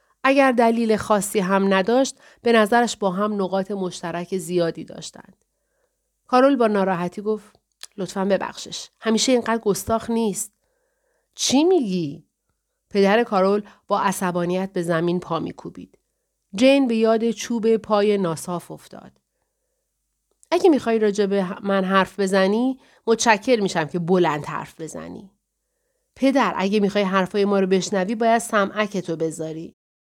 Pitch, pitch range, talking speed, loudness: 210 Hz, 190-240 Hz, 125 wpm, -21 LUFS